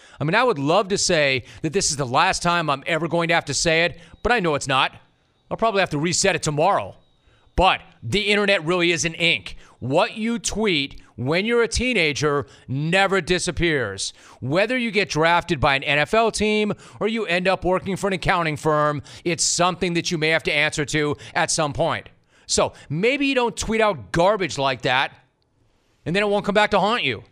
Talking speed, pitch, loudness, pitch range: 210 wpm, 170 Hz, -21 LUFS, 150-200 Hz